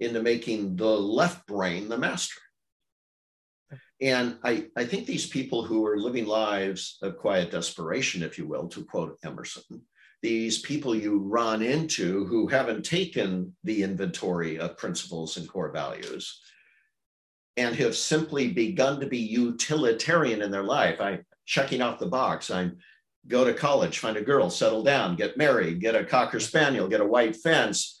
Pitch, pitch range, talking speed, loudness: 110 Hz, 95-120 Hz, 160 wpm, -27 LUFS